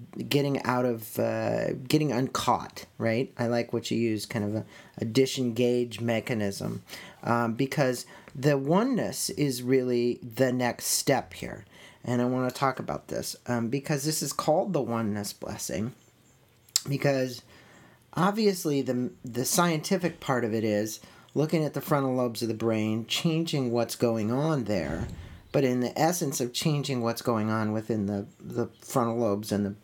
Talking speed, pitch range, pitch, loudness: 165 wpm, 115-145 Hz, 125 Hz, -28 LUFS